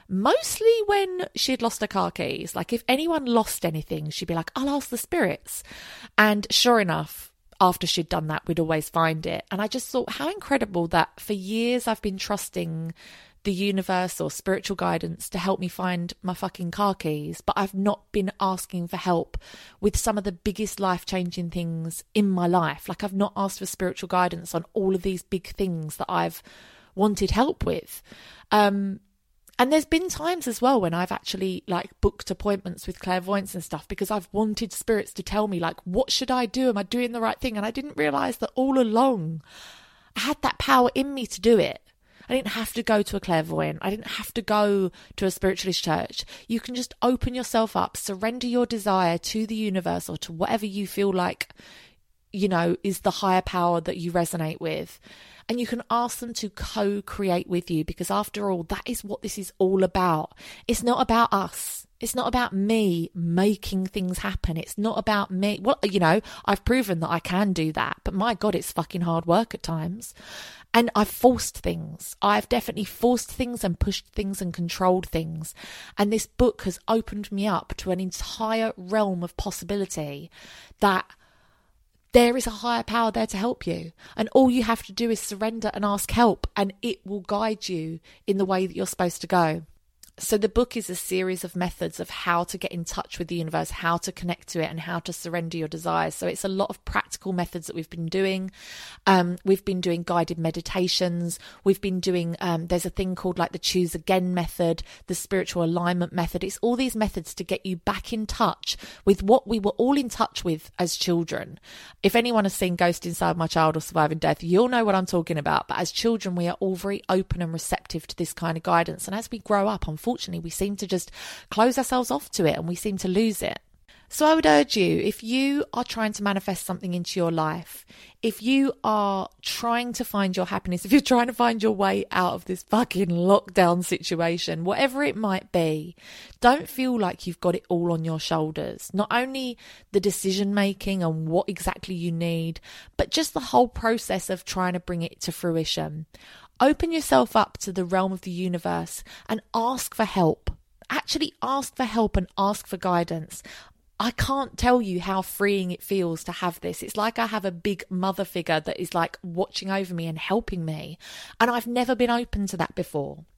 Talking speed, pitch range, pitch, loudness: 210 wpm, 175-220 Hz, 195 Hz, -25 LUFS